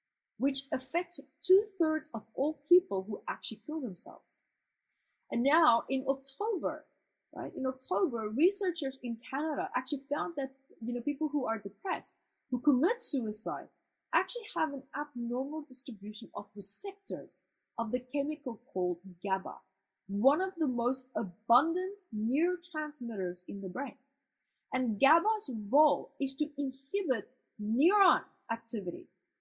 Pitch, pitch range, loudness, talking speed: 270 Hz, 230-310 Hz, -33 LUFS, 125 wpm